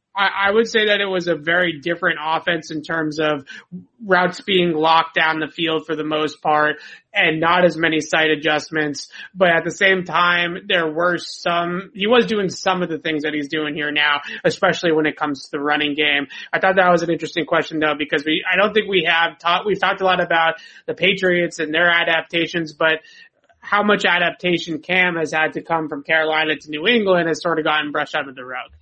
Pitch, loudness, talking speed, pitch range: 165 Hz, -18 LUFS, 220 wpm, 155-180 Hz